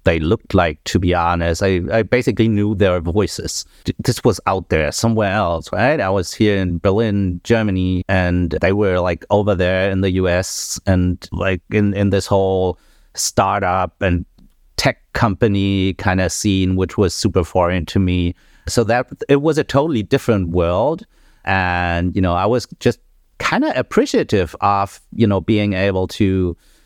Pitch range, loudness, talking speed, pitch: 90-105 Hz, -17 LUFS, 170 wpm, 95 Hz